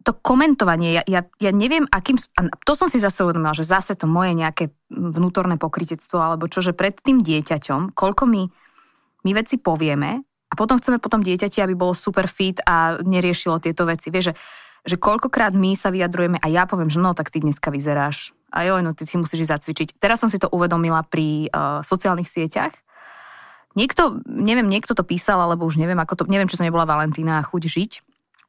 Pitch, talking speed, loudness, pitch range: 180 Hz, 200 wpm, -20 LUFS, 165-200 Hz